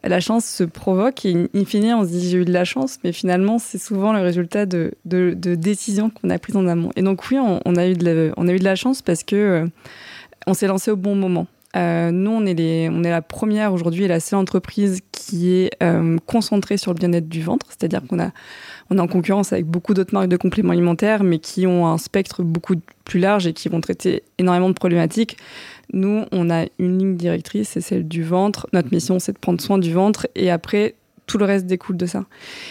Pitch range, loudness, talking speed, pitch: 175-205 Hz, -19 LUFS, 240 wpm, 185 Hz